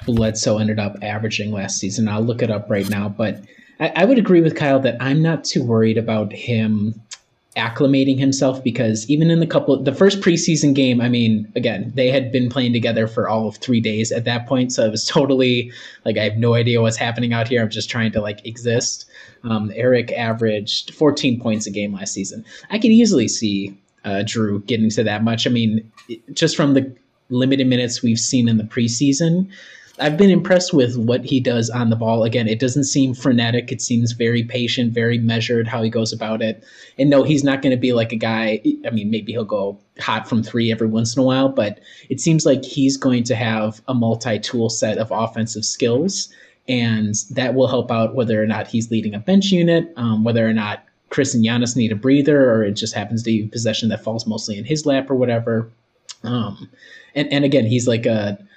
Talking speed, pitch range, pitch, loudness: 220 wpm, 110-135 Hz, 115 Hz, -18 LUFS